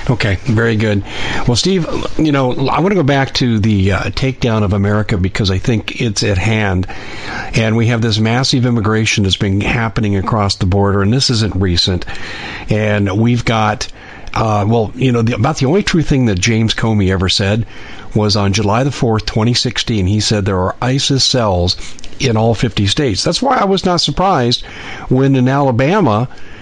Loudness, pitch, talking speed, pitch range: -14 LUFS, 110 Hz, 185 wpm, 100-130 Hz